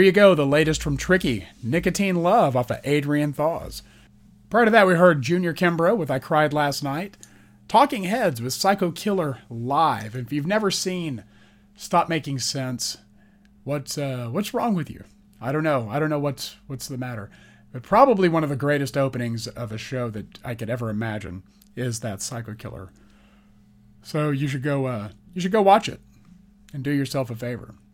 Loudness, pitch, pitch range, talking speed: -23 LUFS, 135 Hz, 110-165 Hz, 190 wpm